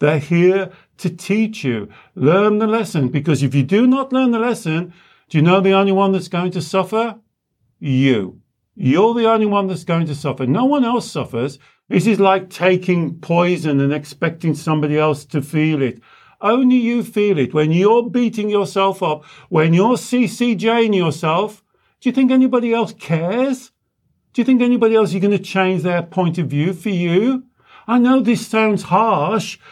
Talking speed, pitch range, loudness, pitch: 180 wpm, 160-225 Hz, -17 LUFS, 190 Hz